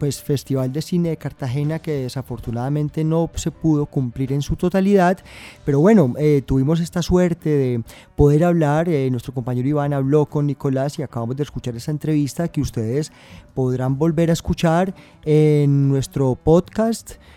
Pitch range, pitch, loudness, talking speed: 135-160 Hz, 145 Hz, -20 LUFS, 160 wpm